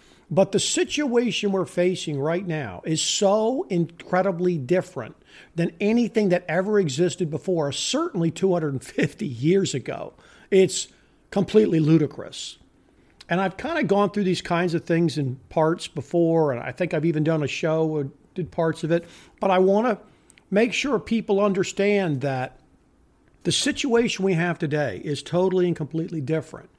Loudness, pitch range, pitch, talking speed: -23 LUFS, 160-200 Hz, 175 Hz, 155 wpm